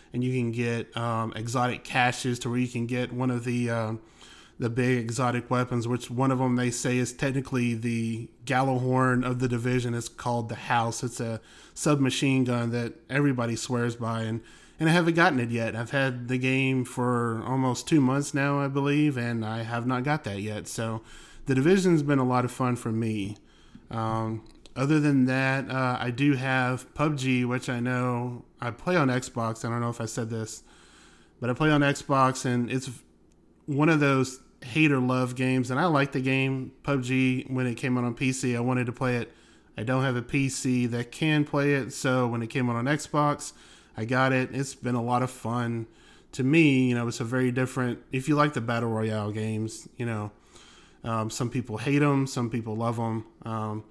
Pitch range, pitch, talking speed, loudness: 115-130 Hz, 125 Hz, 205 wpm, -27 LUFS